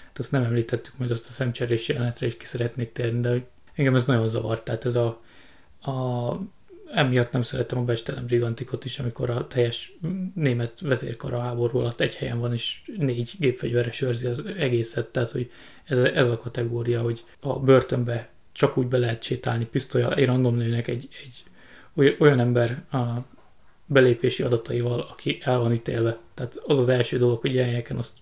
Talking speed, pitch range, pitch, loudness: 175 wpm, 120-130 Hz, 120 Hz, -25 LUFS